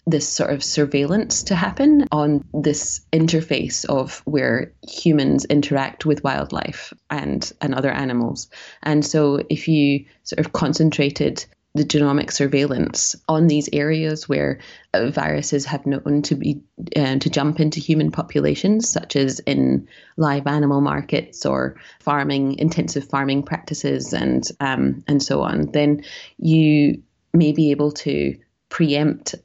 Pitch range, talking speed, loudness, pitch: 140-155 Hz, 140 wpm, -20 LUFS, 145 Hz